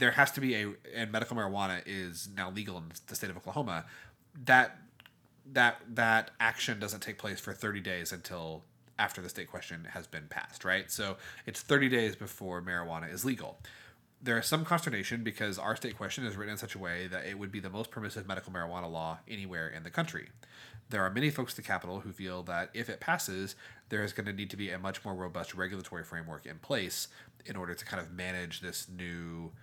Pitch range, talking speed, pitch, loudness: 90-115 Hz, 215 wpm, 100 Hz, -35 LUFS